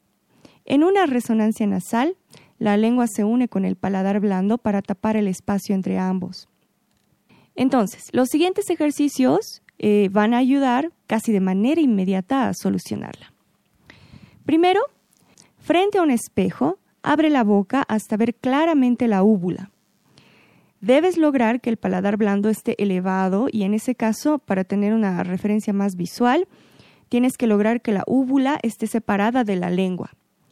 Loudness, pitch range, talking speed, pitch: -20 LUFS, 200-260 Hz, 145 wpm, 220 Hz